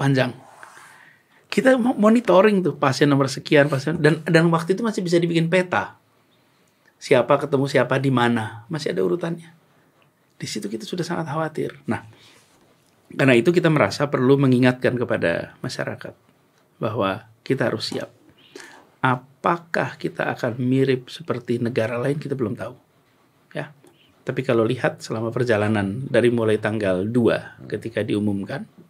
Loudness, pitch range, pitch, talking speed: -21 LUFS, 120-165 Hz, 135 Hz, 135 wpm